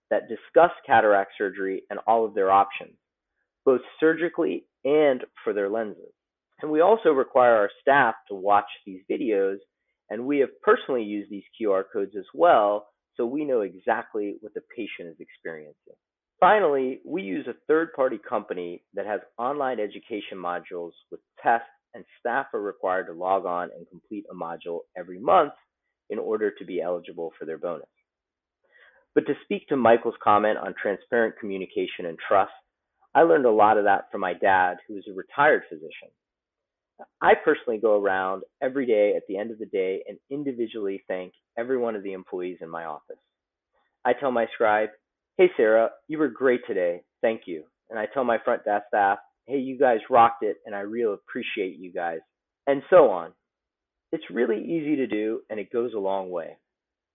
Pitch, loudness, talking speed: 120 Hz, -24 LUFS, 180 wpm